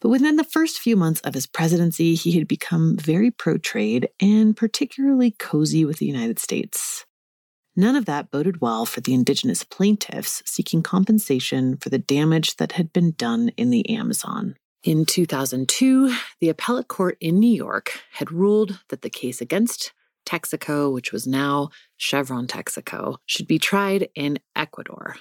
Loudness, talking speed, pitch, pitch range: -21 LUFS, 160 wpm, 175 Hz, 145-225 Hz